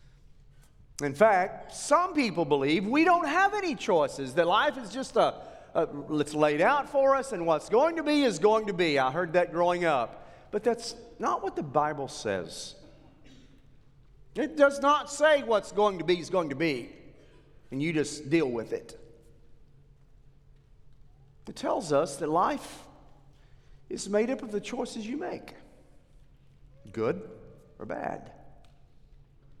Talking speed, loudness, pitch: 155 wpm, -27 LUFS, 160 Hz